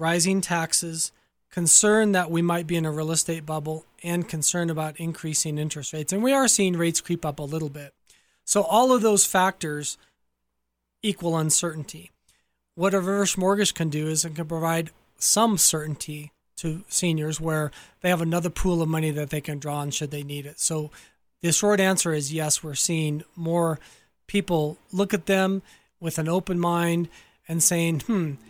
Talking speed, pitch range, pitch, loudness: 180 wpm, 155-180 Hz, 165 Hz, -24 LUFS